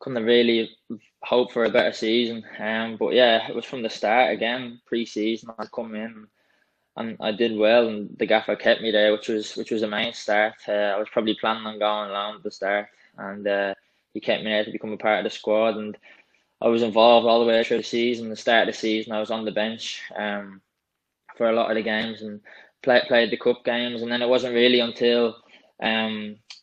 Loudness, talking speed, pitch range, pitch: -23 LUFS, 230 wpm, 105-115 Hz, 110 Hz